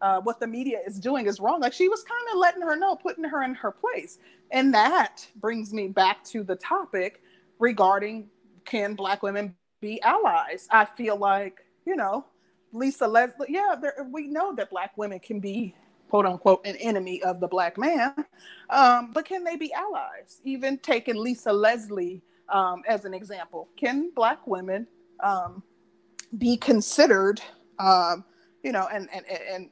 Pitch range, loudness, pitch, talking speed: 195-280 Hz, -25 LUFS, 225 Hz, 170 wpm